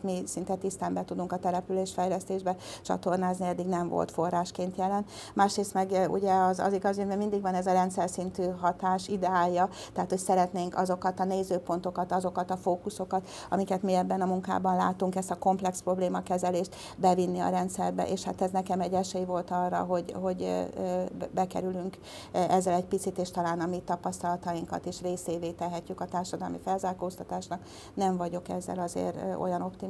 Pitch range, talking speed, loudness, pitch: 180-190 Hz, 165 wpm, -30 LUFS, 180 Hz